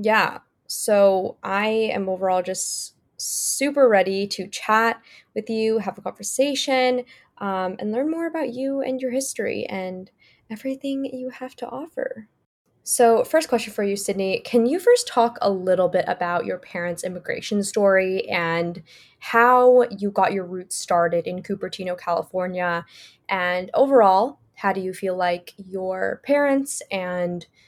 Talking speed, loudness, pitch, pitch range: 145 wpm, -22 LUFS, 200 Hz, 185-250 Hz